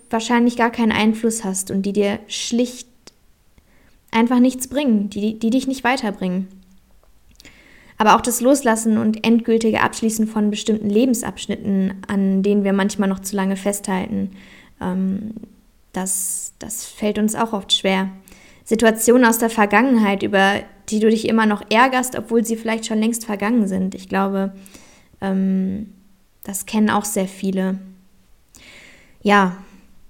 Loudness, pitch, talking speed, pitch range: -19 LUFS, 210 Hz, 140 wpm, 195-225 Hz